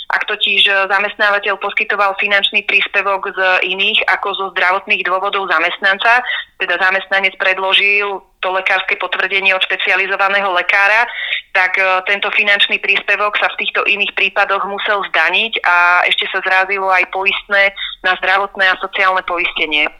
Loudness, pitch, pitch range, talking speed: -13 LUFS, 195 Hz, 185-200 Hz, 130 wpm